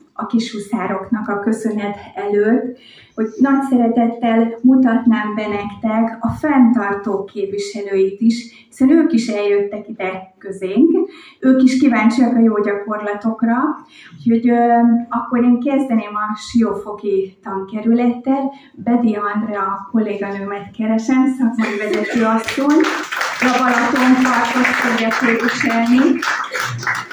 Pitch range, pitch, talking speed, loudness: 210-250 Hz, 230 Hz, 100 wpm, -16 LUFS